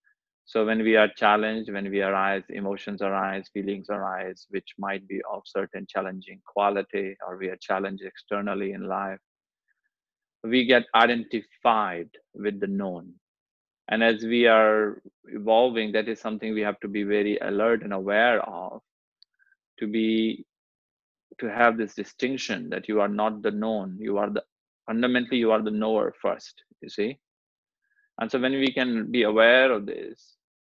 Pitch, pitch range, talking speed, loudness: 110 Hz, 100-115 Hz, 160 wpm, -25 LUFS